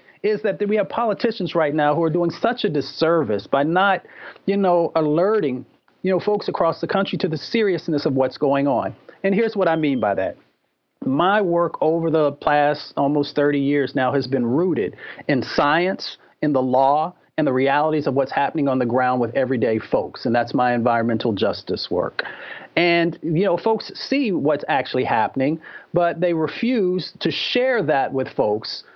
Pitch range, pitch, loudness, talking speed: 140-190 Hz, 160 Hz, -20 LUFS, 185 wpm